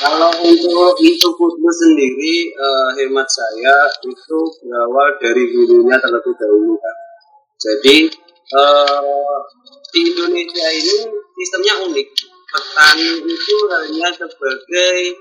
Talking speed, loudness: 100 wpm, -13 LUFS